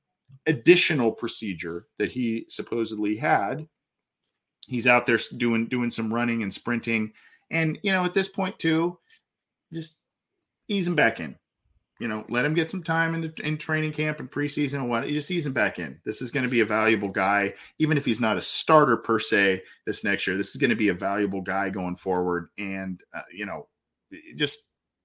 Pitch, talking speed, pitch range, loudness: 120 Hz, 195 wpm, 105-160 Hz, -25 LUFS